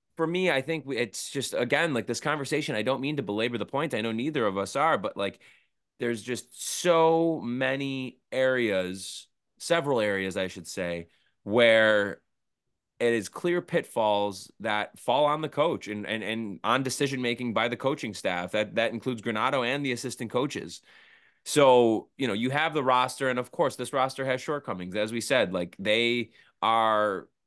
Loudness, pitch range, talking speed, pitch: -27 LUFS, 105-135 Hz, 180 wpm, 120 Hz